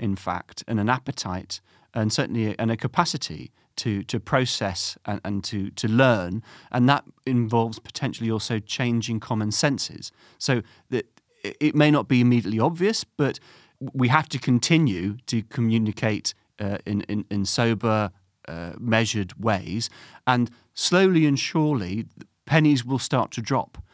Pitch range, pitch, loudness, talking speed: 105-130 Hz, 115 Hz, -24 LUFS, 150 wpm